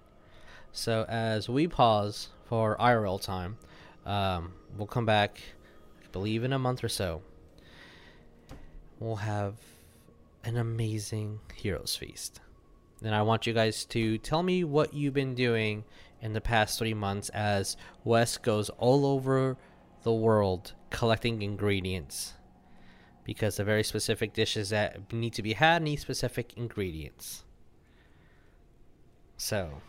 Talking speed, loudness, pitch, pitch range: 130 wpm, -30 LUFS, 110 Hz, 95-115 Hz